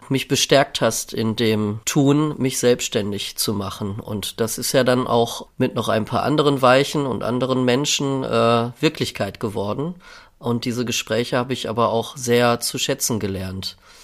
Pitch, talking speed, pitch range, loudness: 120 Hz, 165 wpm, 110-135 Hz, -20 LUFS